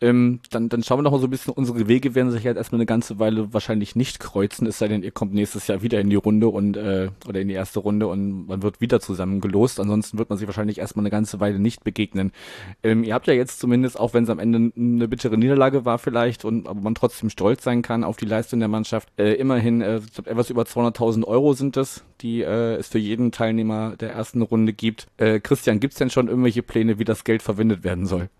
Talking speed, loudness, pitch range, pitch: 255 wpm, -22 LUFS, 105-120 Hz, 115 Hz